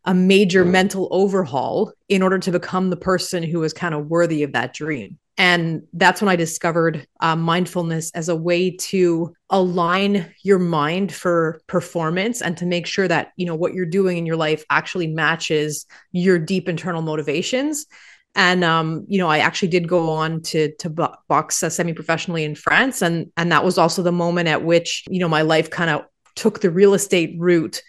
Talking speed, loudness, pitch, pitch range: 190 wpm, -19 LUFS, 175 Hz, 160-185 Hz